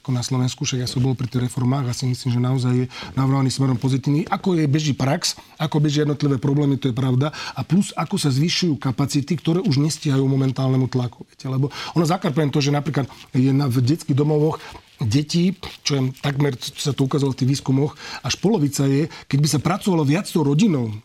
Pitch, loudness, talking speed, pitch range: 140 Hz, -21 LUFS, 210 wpm, 130-150 Hz